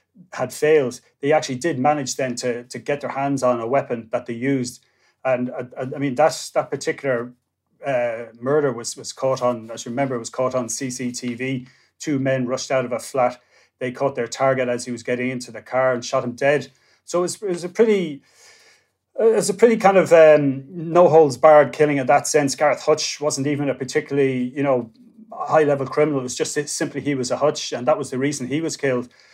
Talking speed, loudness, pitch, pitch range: 225 wpm, -20 LUFS, 135 Hz, 125-150 Hz